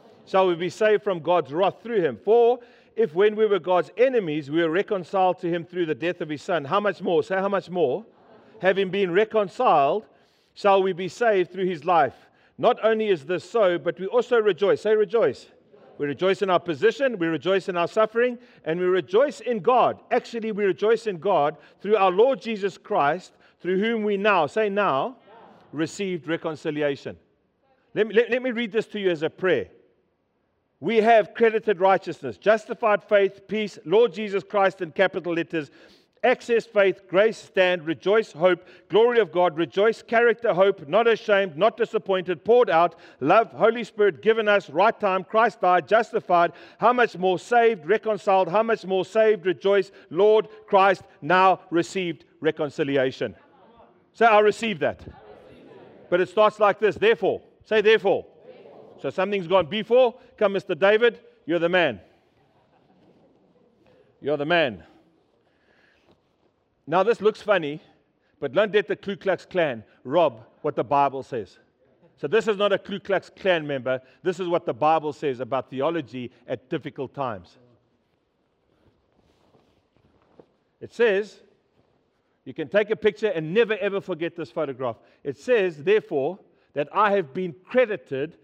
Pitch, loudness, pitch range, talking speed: 195 Hz, -23 LUFS, 170-220 Hz, 160 wpm